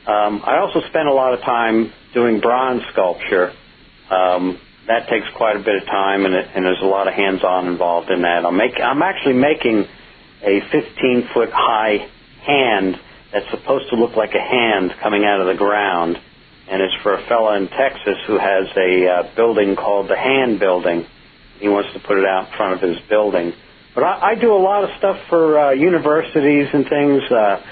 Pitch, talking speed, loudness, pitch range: 105 Hz, 195 wpm, -17 LUFS, 95-130 Hz